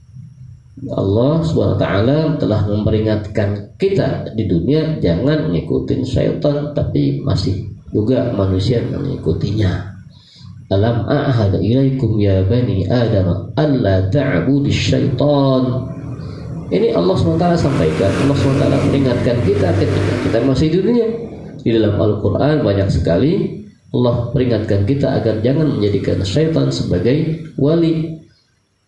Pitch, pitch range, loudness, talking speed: 125 Hz, 105-145 Hz, -16 LUFS, 95 wpm